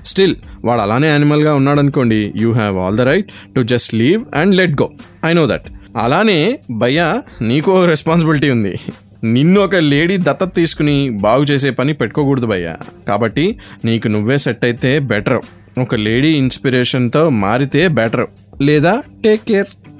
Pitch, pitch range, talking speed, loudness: 140 Hz, 115-155 Hz, 150 wpm, -13 LUFS